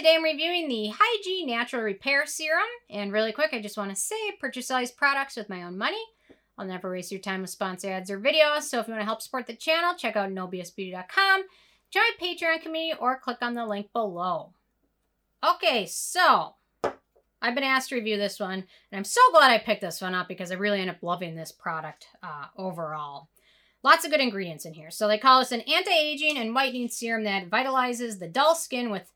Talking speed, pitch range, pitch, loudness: 215 wpm, 195-300 Hz, 230 Hz, -25 LUFS